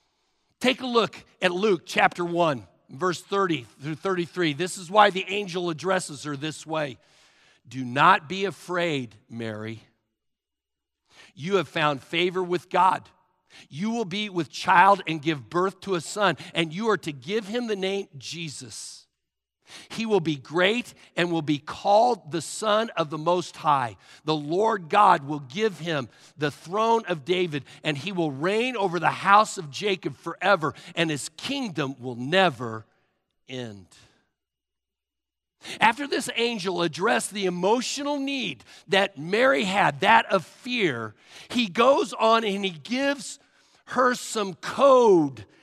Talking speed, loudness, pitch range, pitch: 150 wpm, -24 LUFS, 150-210 Hz, 180 Hz